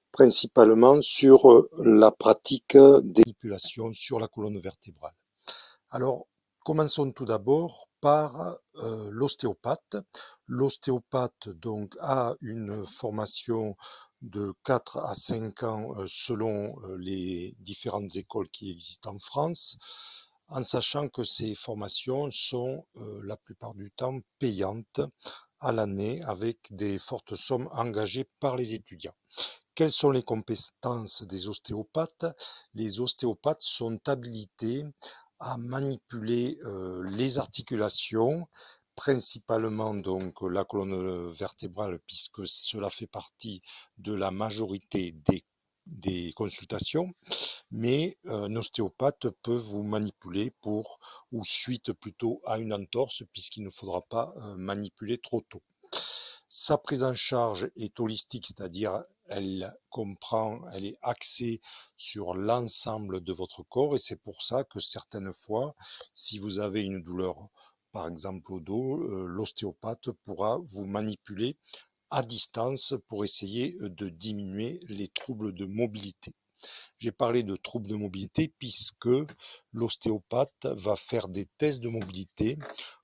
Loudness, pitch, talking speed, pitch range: -28 LUFS, 110 Hz, 125 wpm, 100-125 Hz